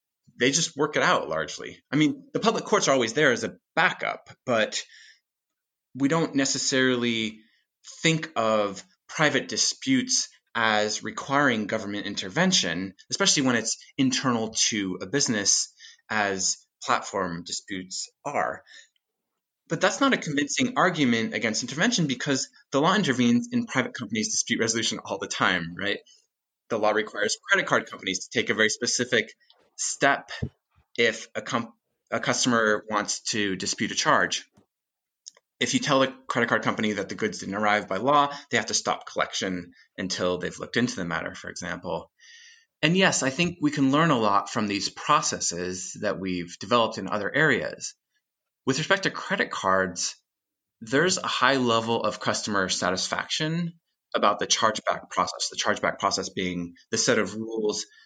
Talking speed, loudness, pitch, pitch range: 155 wpm, -25 LUFS, 125 Hz, 105-160 Hz